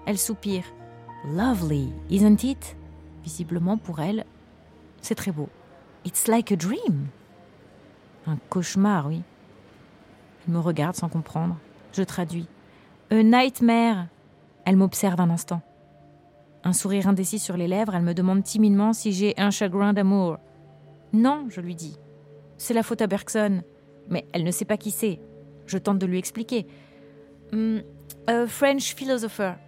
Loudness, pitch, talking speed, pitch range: -24 LUFS, 185 Hz, 145 wpm, 155-210 Hz